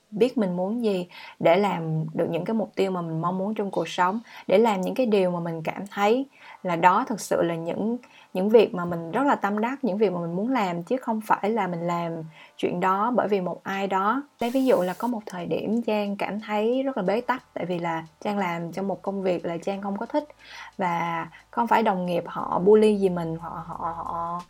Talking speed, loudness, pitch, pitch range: 245 wpm, -25 LUFS, 195 Hz, 175-220 Hz